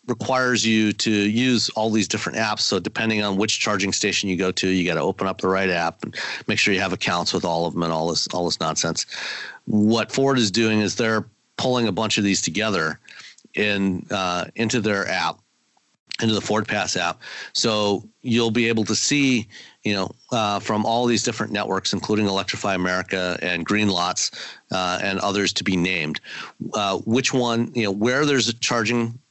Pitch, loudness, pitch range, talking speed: 105 Hz, -22 LUFS, 95-115 Hz, 200 wpm